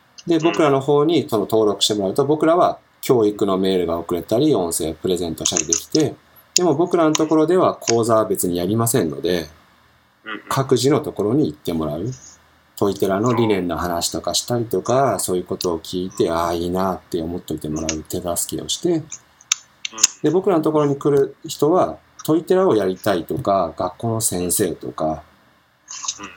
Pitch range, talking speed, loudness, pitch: 85-145 Hz, 350 characters per minute, -19 LUFS, 100 Hz